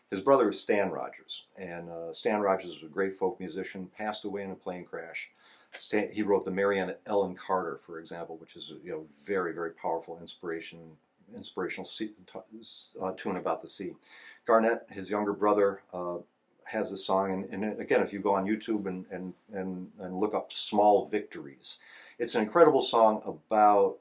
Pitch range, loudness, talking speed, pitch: 90-105 Hz, -30 LUFS, 185 wpm, 95 Hz